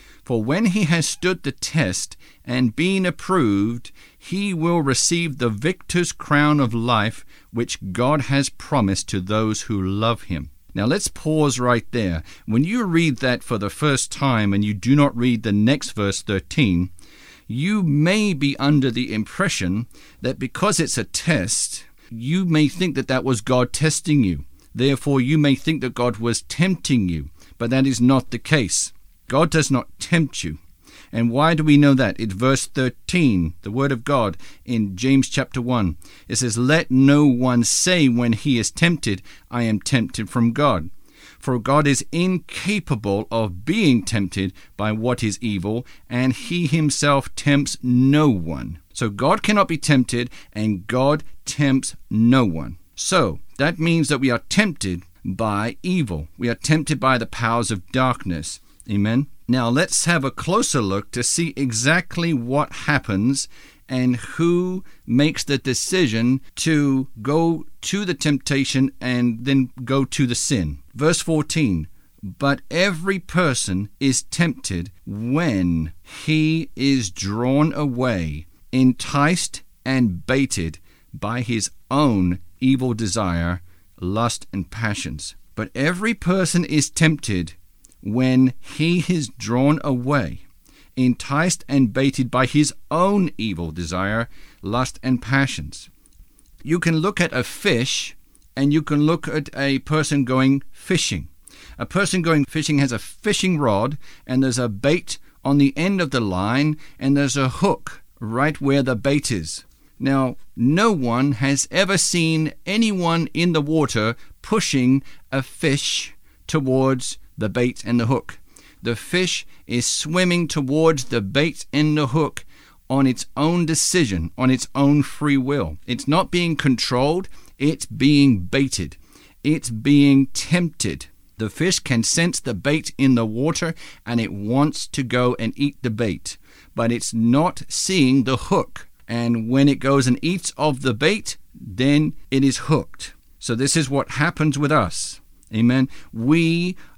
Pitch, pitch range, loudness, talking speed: 130 Hz, 115-150 Hz, -20 LUFS, 150 wpm